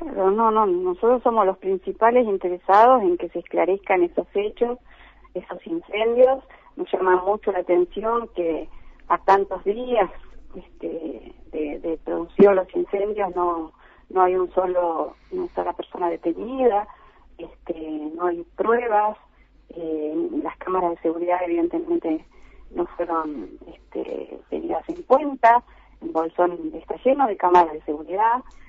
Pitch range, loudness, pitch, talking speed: 175-240 Hz, -22 LUFS, 190 Hz, 130 wpm